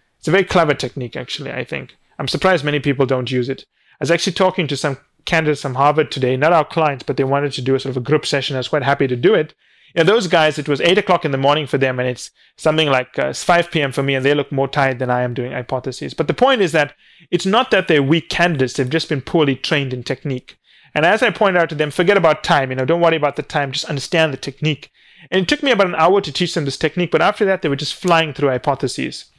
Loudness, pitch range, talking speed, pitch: -17 LUFS, 135-165 Hz, 280 wpm, 150 Hz